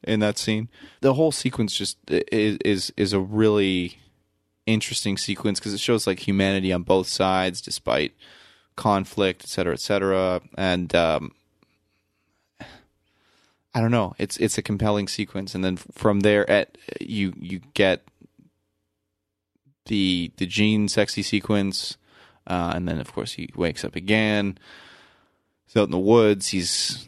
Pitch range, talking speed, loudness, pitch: 95-105 Hz, 145 wpm, -23 LUFS, 100 Hz